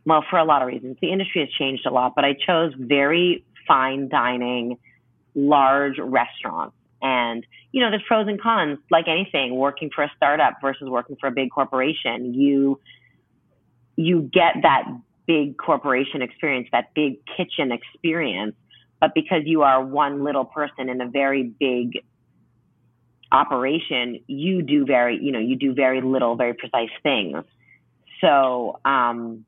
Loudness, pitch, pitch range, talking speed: -21 LUFS, 135 Hz, 125-150 Hz, 155 wpm